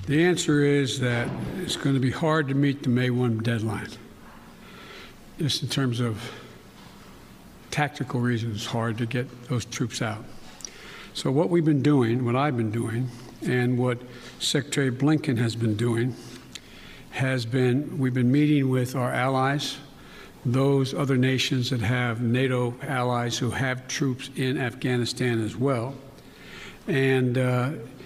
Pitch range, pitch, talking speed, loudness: 120-135 Hz, 125 Hz, 145 wpm, -25 LUFS